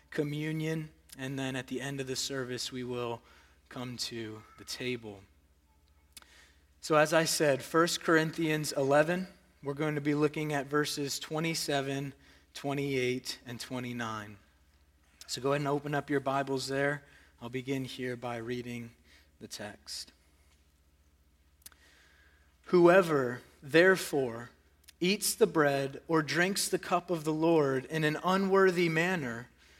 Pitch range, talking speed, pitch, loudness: 105-155 Hz, 130 wpm, 135 Hz, -31 LUFS